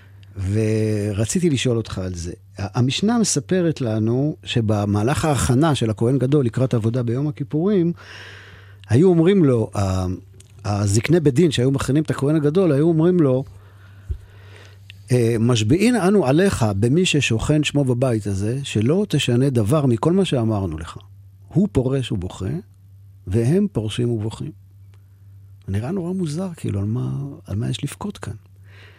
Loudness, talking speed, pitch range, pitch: -20 LUFS, 130 wpm, 100-150 Hz, 120 Hz